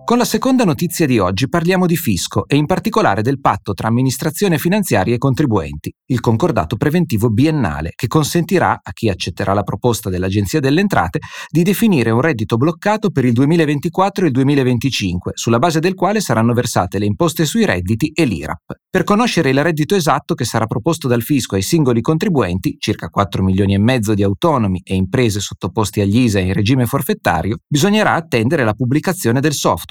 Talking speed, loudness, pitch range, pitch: 180 wpm, -16 LUFS, 110-170 Hz, 130 Hz